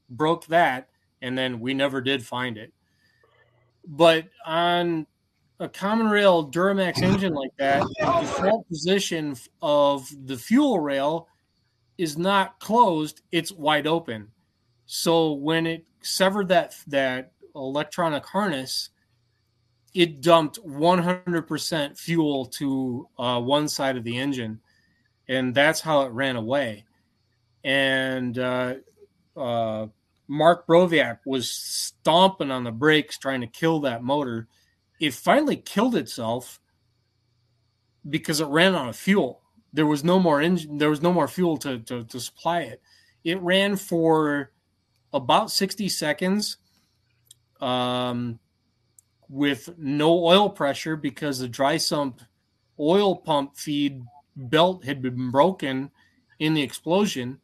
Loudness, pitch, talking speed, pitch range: -23 LUFS, 140 Hz, 125 wpm, 120-165 Hz